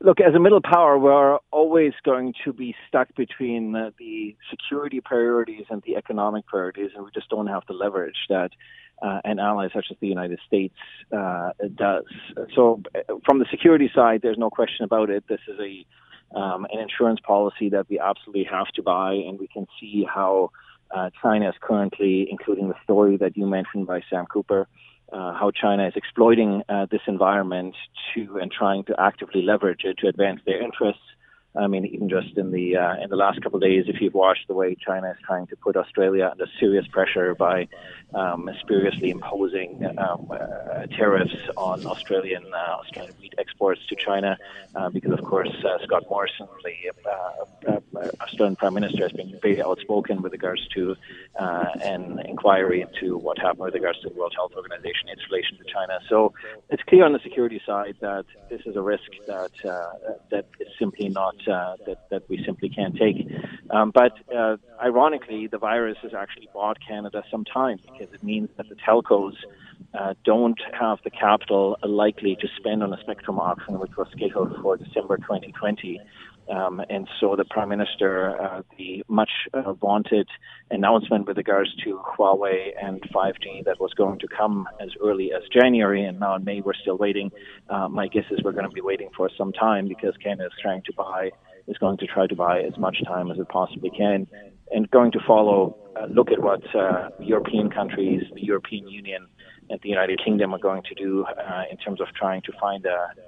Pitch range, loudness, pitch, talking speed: 95-125 Hz, -23 LUFS, 105 Hz, 195 wpm